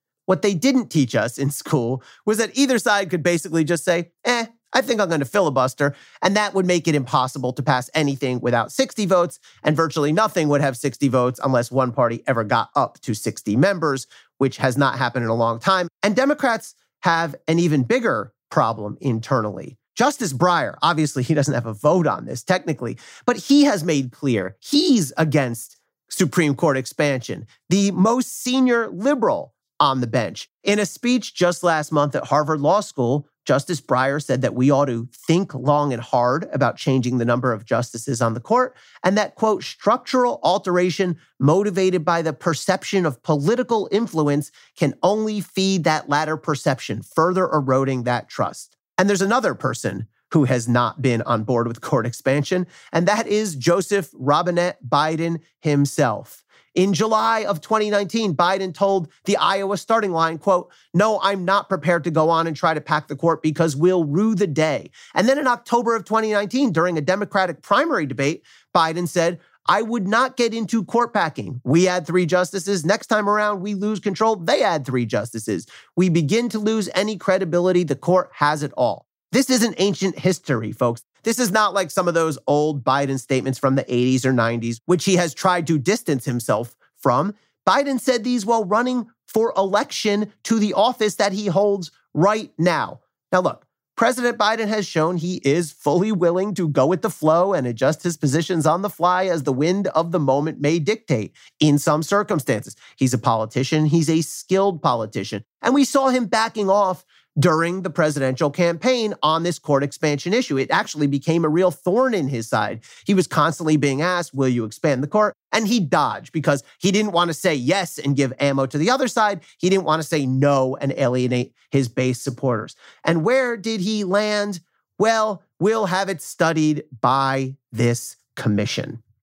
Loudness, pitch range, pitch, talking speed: -20 LUFS, 140-205 Hz, 165 Hz, 185 wpm